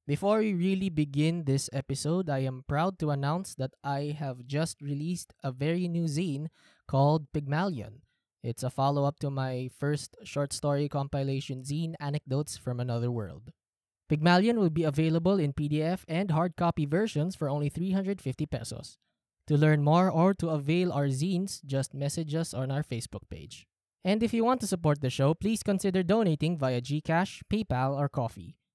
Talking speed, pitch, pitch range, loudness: 170 wpm, 150 Hz, 135-170 Hz, -30 LUFS